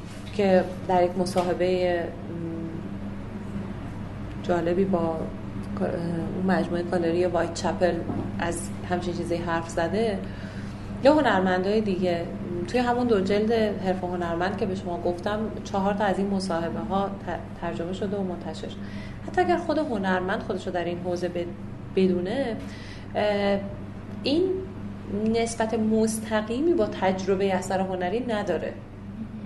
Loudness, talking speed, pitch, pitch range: -26 LUFS, 115 wpm, 180 Hz, 165-205 Hz